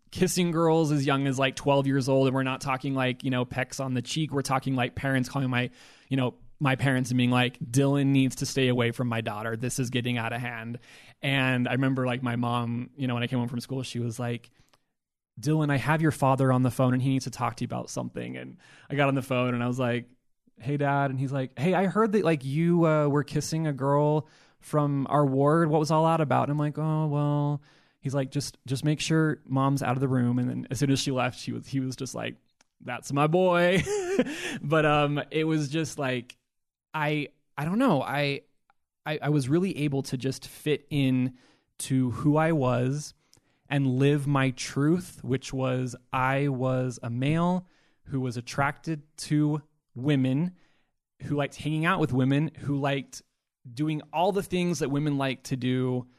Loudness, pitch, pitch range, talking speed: -27 LUFS, 135 Hz, 125-150 Hz, 215 wpm